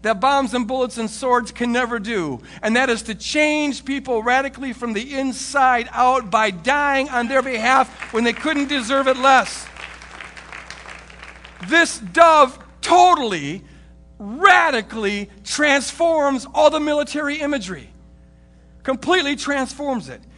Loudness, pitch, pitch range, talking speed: -18 LUFS, 260 Hz, 225-285 Hz, 125 wpm